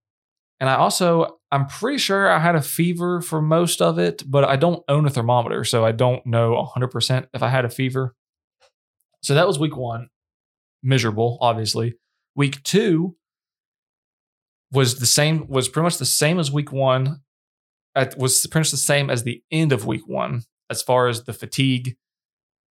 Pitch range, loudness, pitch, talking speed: 120-155 Hz, -20 LUFS, 135 Hz, 175 wpm